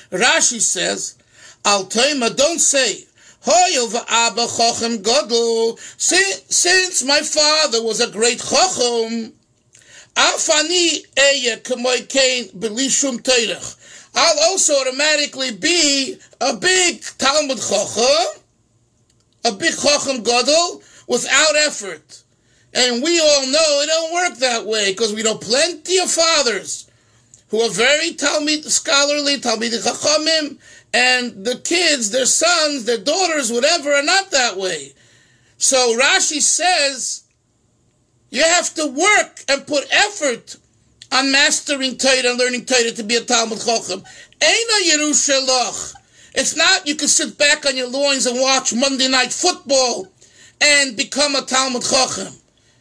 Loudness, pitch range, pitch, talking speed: -15 LUFS, 230-305 Hz, 265 Hz, 115 wpm